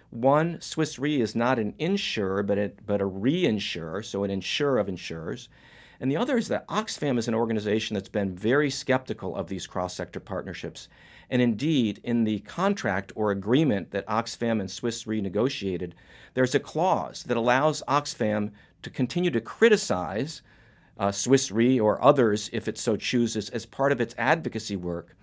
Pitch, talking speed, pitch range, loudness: 115 Hz, 165 wpm, 100-135 Hz, -26 LUFS